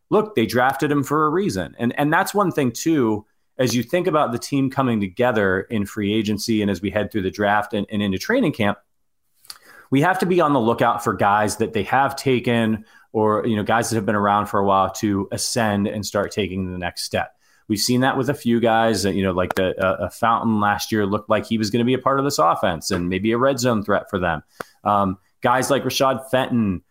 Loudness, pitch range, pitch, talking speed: -20 LUFS, 100-130 Hz, 110 Hz, 245 wpm